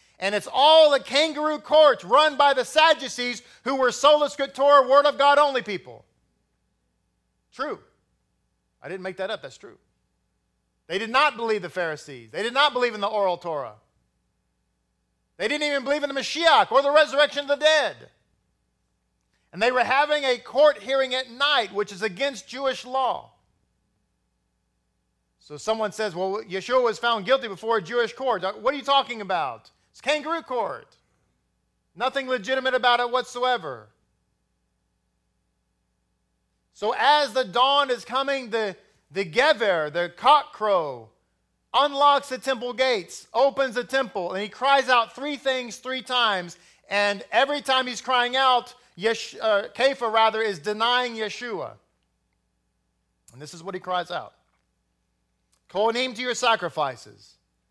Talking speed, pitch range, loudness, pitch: 150 wpm, 175-270 Hz, -22 LUFS, 240 Hz